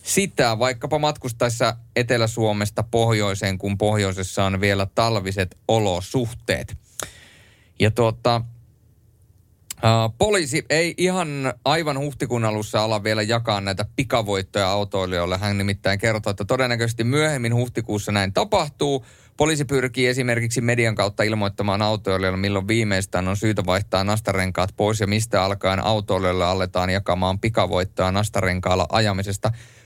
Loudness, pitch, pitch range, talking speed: -22 LUFS, 110 Hz, 100-120 Hz, 115 wpm